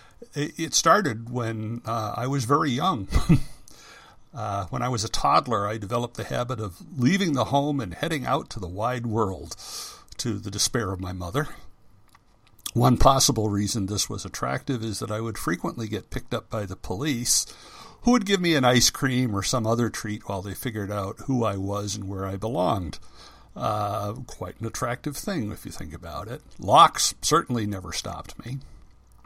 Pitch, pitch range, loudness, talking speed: 115 Hz, 100-135 Hz, -25 LUFS, 185 wpm